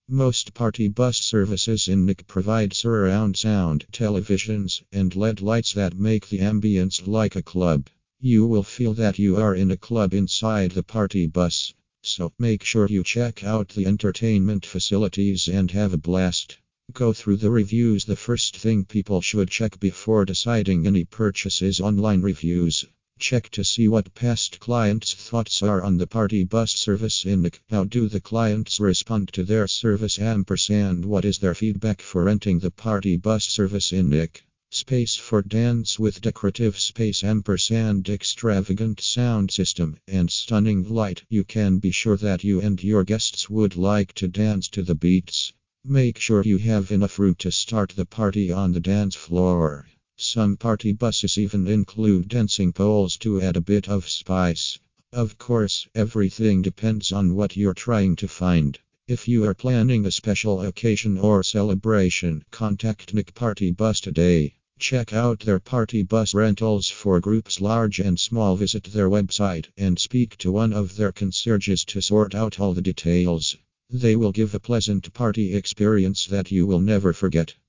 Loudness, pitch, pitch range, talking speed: -22 LUFS, 100 Hz, 95-110 Hz, 170 wpm